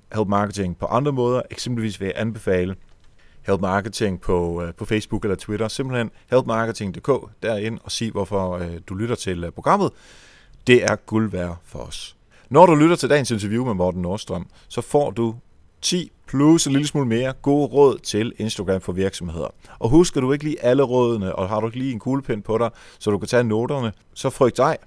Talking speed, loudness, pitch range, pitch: 195 wpm, -21 LUFS, 95-125 Hz, 110 Hz